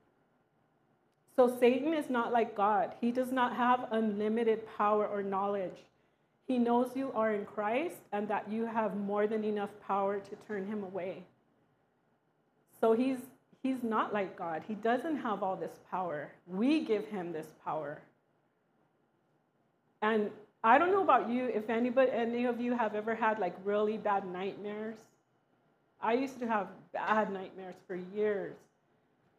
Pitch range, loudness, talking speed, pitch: 200-240 Hz, -33 LUFS, 155 wpm, 215 Hz